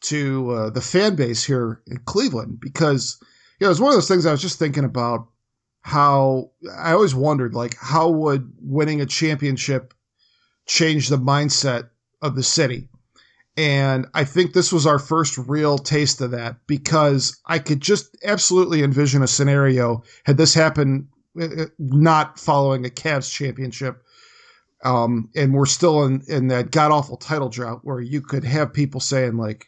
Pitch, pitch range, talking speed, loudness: 140 Hz, 130-155 Hz, 170 wpm, -19 LUFS